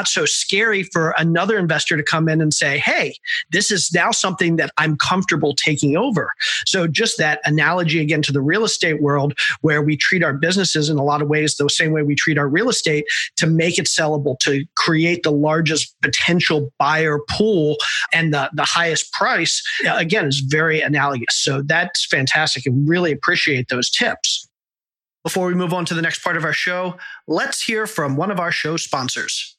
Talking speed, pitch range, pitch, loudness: 195 wpm, 150-175 Hz, 160 Hz, -17 LUFS